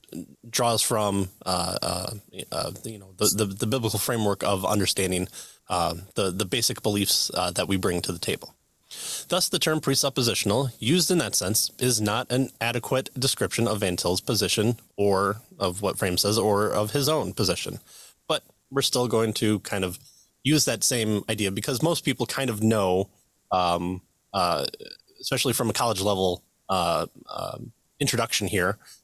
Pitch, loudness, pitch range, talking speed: 110 Hz, -25 LUFS, 100-130 Hz, 165 wpm